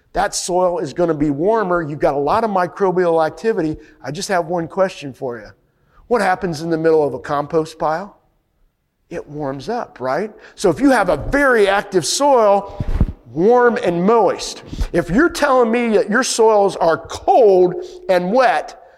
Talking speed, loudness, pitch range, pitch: 175 wpm, -17 LUFS, 160-225 Hz, 180 Hz